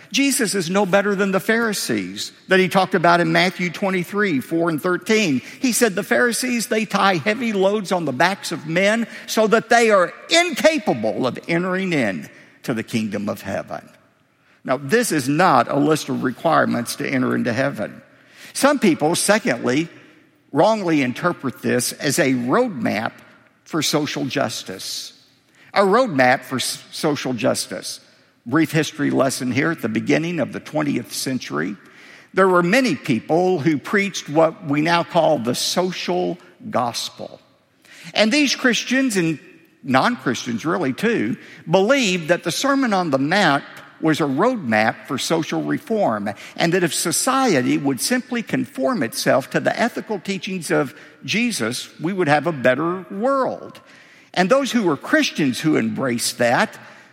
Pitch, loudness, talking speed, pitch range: 185 Hz, -19 LUFS, 150 wpm, 160-230 Hz